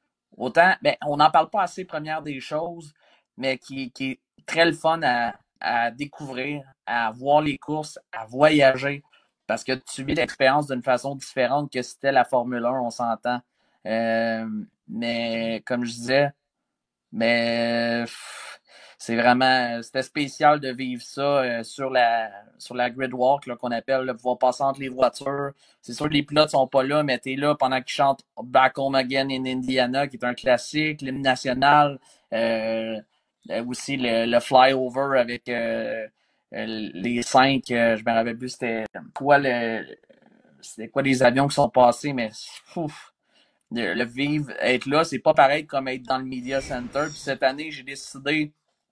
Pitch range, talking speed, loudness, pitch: 120-140 Hz, 165 wpm, -23 LUFS, 130 Hz